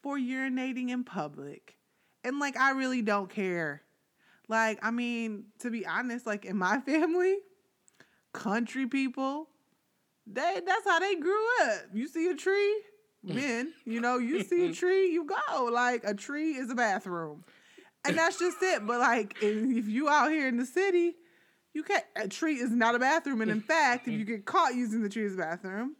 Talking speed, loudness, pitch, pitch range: 185 wpm, -30 LUFS, 255 Hz, 220-320 Hz